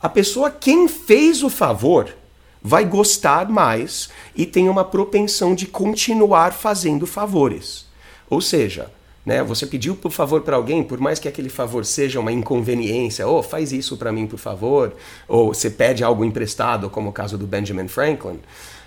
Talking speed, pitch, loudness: 170 wpm, 150 Hz, -18 LUFS